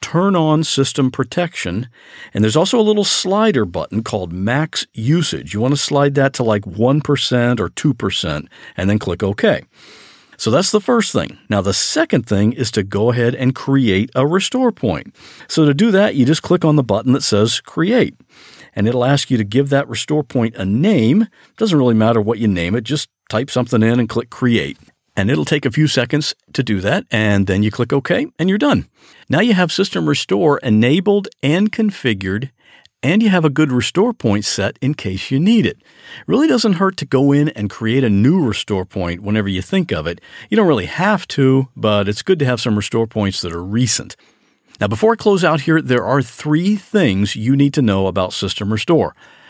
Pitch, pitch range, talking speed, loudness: 130 Hz, 110-160 Hz, 210 wpm, -16 LUFS